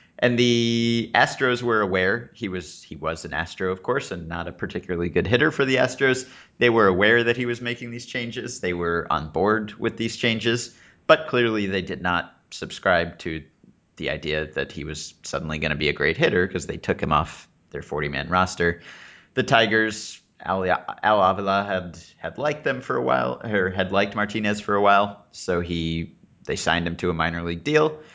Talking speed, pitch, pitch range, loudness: 200 wpm, 95 Hz, 85-115 Hz, -23 LUFS